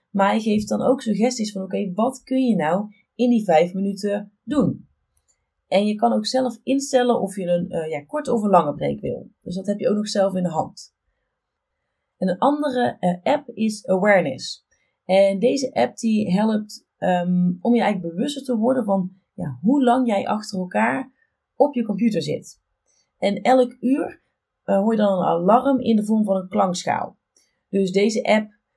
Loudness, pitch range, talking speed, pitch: -21 LUFS, 185-240 Hz, 195 wpm, 210 Hz